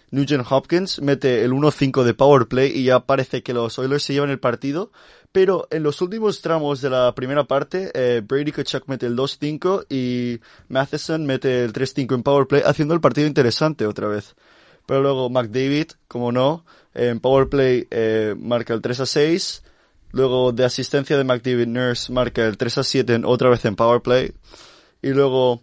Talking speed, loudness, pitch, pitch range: 170 wpm, -20 LUFS, 135 Hz, 125-145 Hz